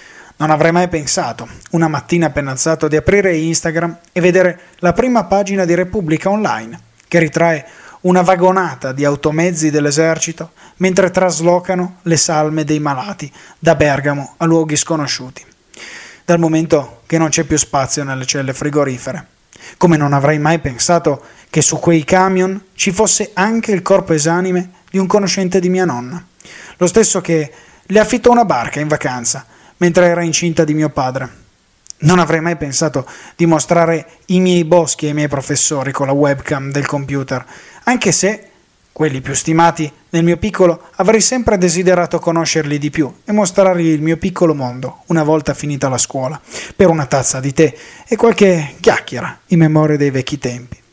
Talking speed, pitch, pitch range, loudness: 165 wpm, 165 Hz, 145-180 Hz, -14 LUFS